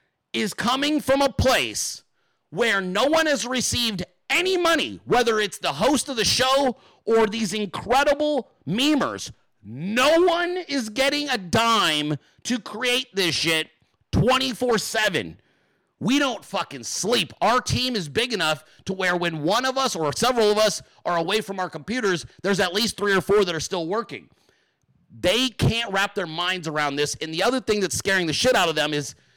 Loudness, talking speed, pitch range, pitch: -22 LUFS, 180 wpm, 175-260 Hz, 215 Hz